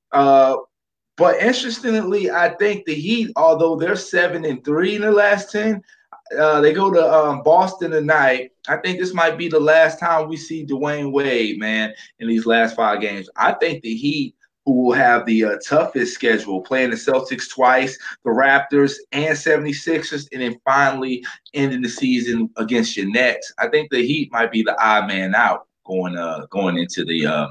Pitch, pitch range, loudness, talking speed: 145 Hz, 115-165 Hz, -18 LUFS, 185 wpm